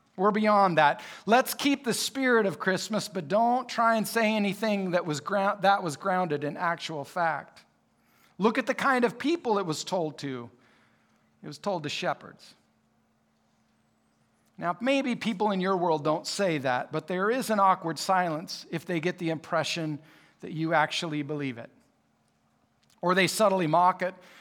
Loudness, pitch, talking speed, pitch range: -27 LUFS, 185 Hz, 170 wpm, 160-215 Hz